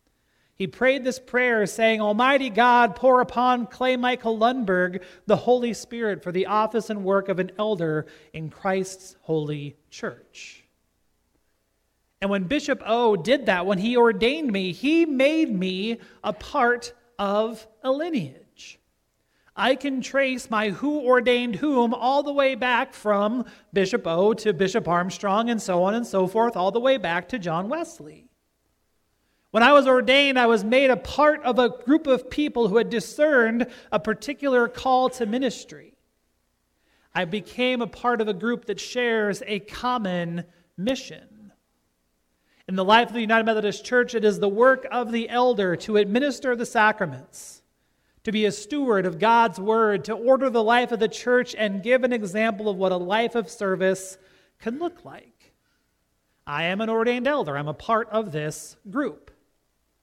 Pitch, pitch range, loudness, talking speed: 225 Hz, 190-250 Hz, -23 LUFS, 165 wpm